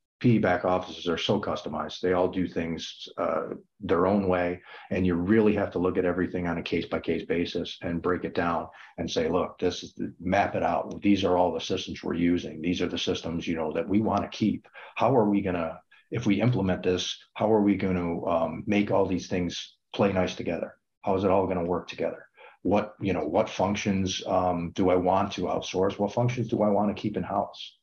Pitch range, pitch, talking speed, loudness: 90-100 Hz, 90 Hz, 230 wpm, -27 LUFS